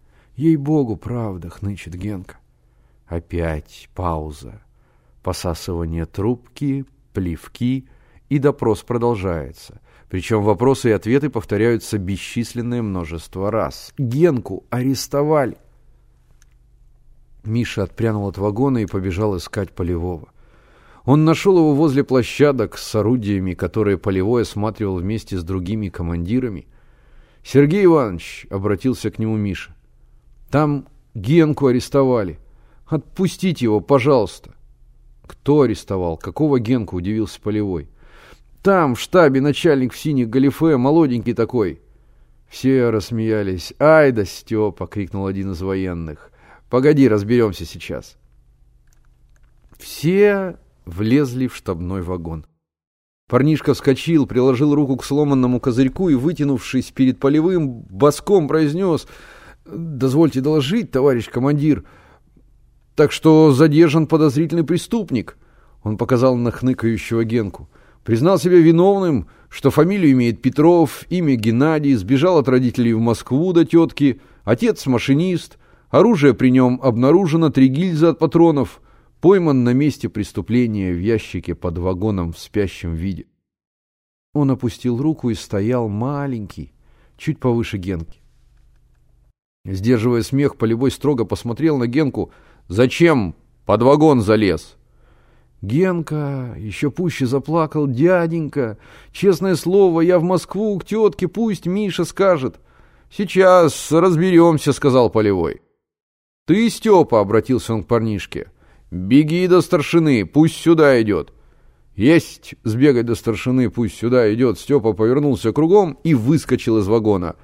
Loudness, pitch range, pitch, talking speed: -17 LUFS, 95-145 Hz, 120 Hz, 110 wpm